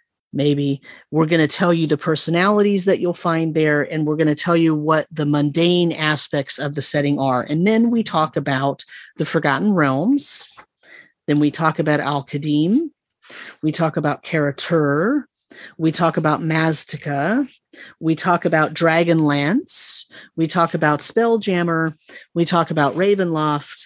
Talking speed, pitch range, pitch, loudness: 155 wpm, 150-175 Hz, 160 Hz, -19 LUFS